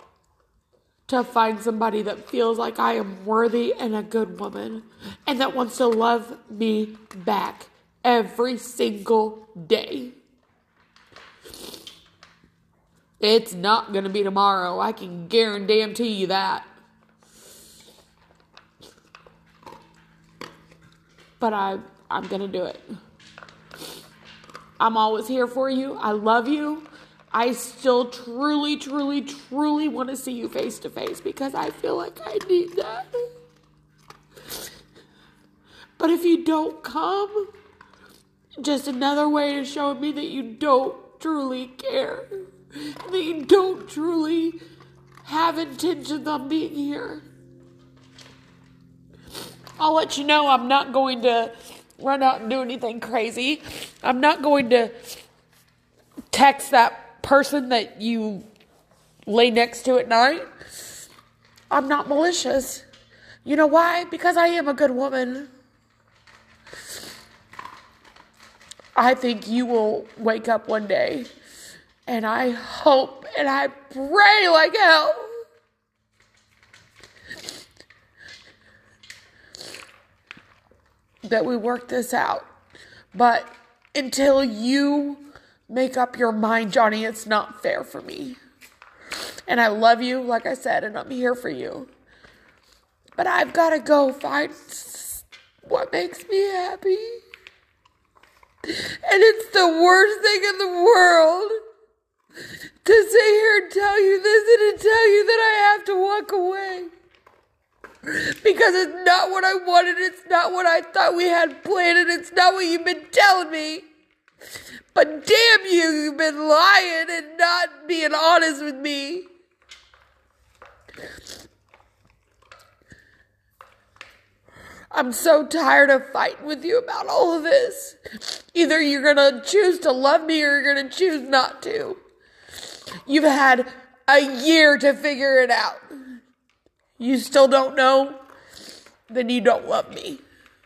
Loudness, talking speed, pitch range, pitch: -20 LUFS, 120 wpm, 240-345 Hz, 285 Hz